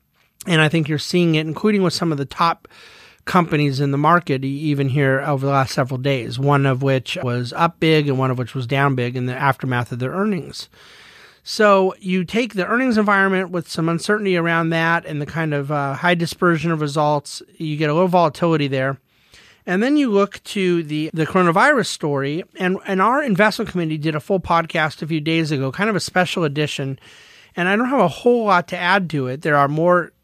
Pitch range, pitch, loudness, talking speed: 140-185 Hz, 165 Hz, -19 LUFS, 215 wpm